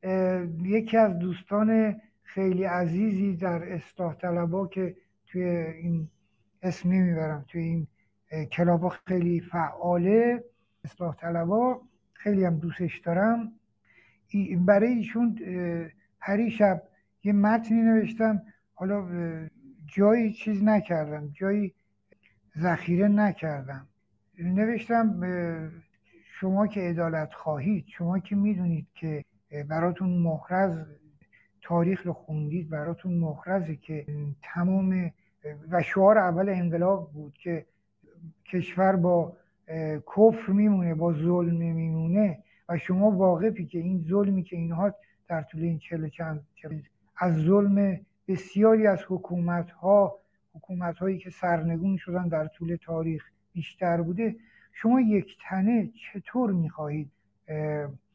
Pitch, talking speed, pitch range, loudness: 175 Hz, 105 wpm, 160-195 Hz, -27 LUFS